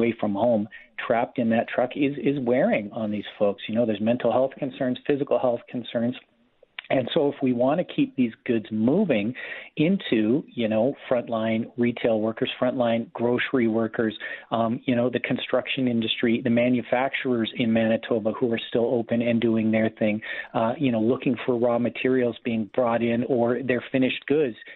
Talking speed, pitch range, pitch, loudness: 175 wpm, 115-125 Hz, 120 Hz, -24 LUFS